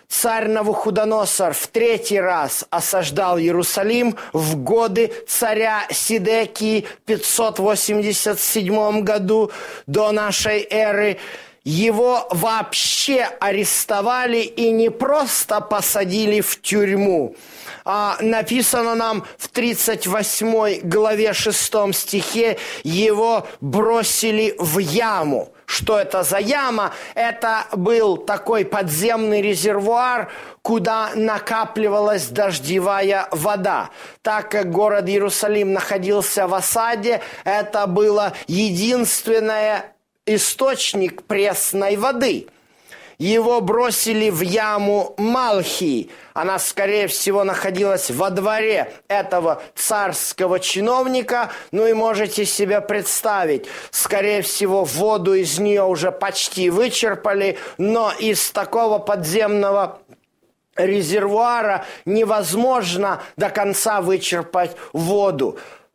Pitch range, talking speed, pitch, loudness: 195-225 Hz, 90 wpm, 210 Hz, -19 LUFS